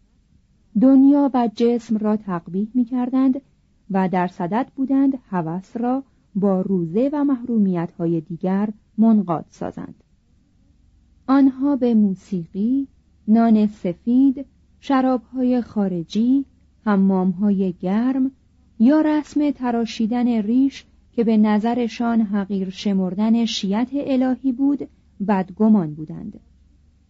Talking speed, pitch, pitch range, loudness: 100 wpm, 220 Hz, 190-255 Hz, -20 LUFS